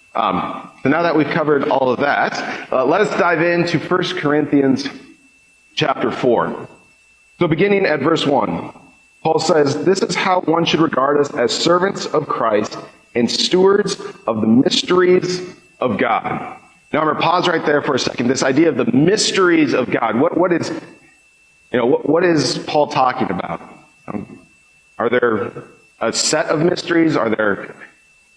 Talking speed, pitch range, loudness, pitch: 175 wpm, 145-180 Hz, -17 LUFS, 165 Hz